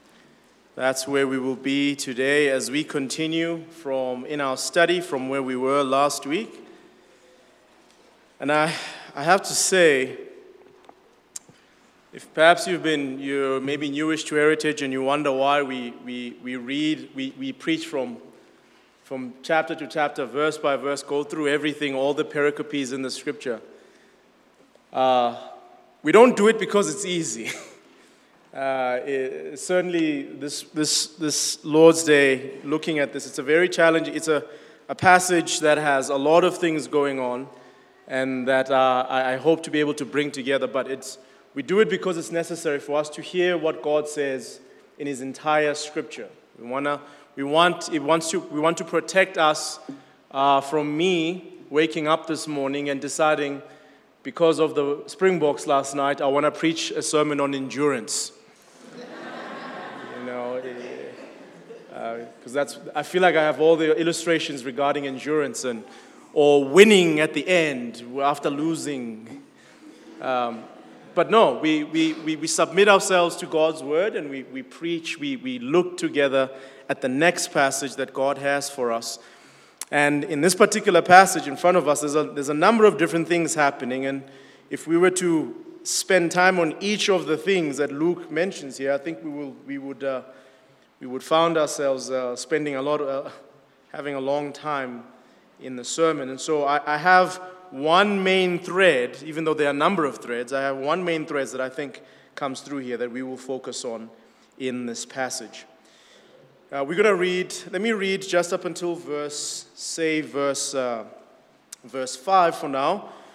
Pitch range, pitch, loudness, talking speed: 135-165 Hz, 150 Hz, -22 LUFS, 175 wpm